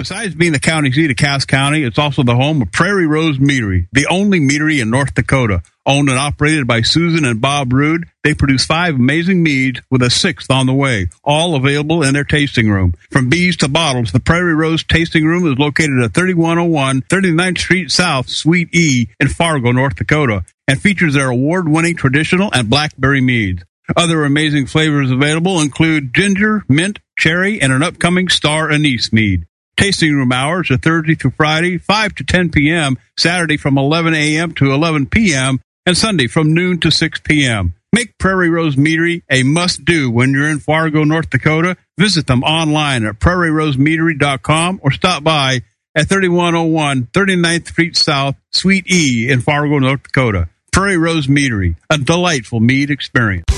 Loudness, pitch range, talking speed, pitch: -13 LUFS, 135-170 Hz, 175 wpm, 150 Hz